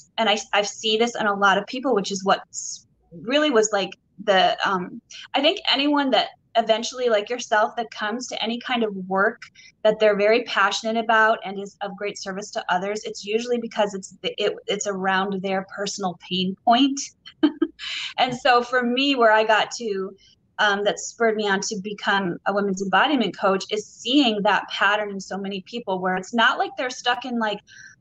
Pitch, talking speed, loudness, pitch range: 215 Hz, 195 wpm, -22 LUFS, 195-240 Hz